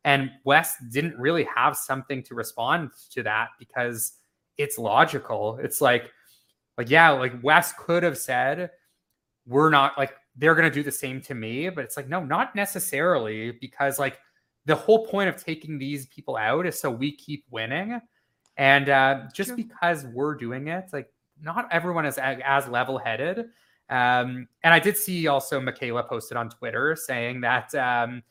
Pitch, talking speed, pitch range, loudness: 140 Hz, 165 wpm, 130-165 Hz, -24 LUFS